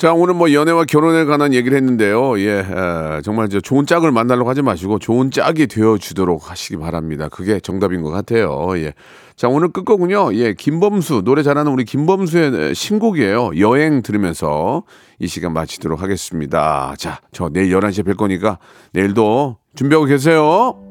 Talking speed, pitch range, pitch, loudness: 360 characters per minute, 95-150 Hz, 115 Hz, -16 LUFS